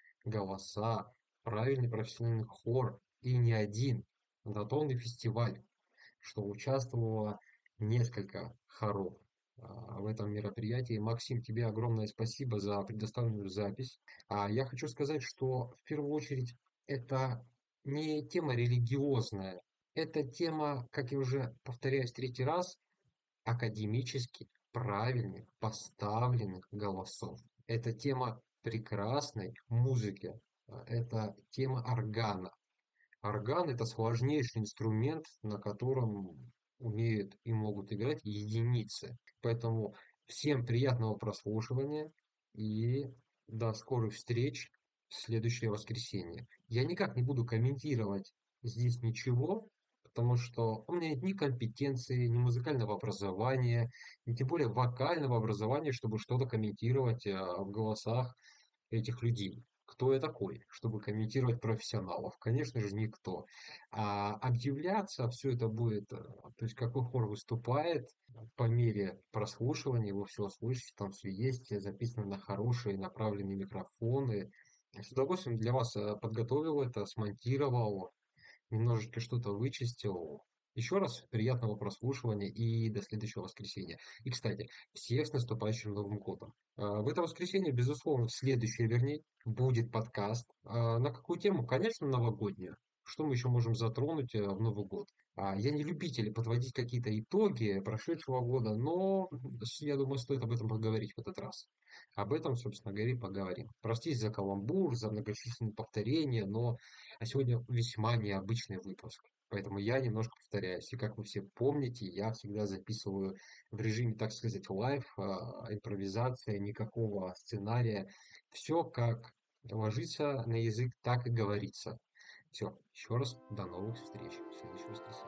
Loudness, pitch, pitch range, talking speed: -37 LUFS, 115 Hz, 105-130 Hz, 120 wpm